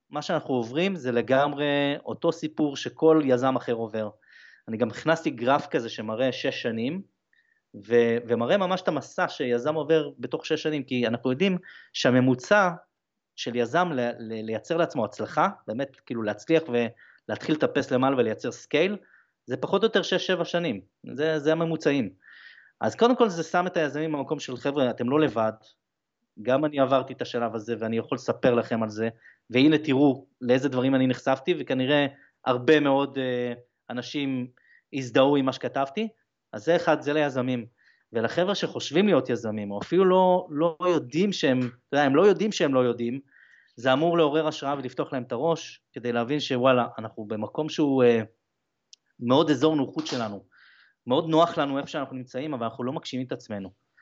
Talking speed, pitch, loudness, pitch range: 170 wpm, 135 Hz, -25 LUFS, 120-155 Hz